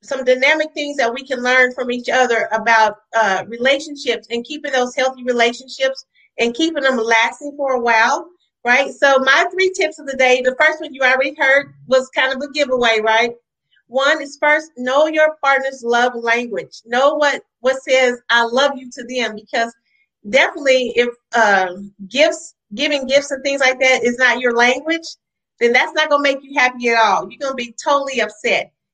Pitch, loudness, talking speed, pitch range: 260 Hz, -16 LUFS, 190 wpm, 235-285 Hz